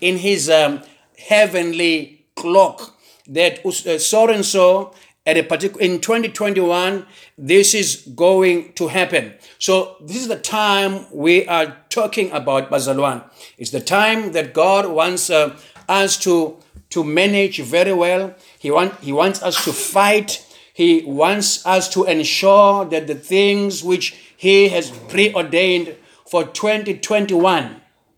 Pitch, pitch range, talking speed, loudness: 185 Hz, 160-200 Hz, 135 wpm, -16 LUFS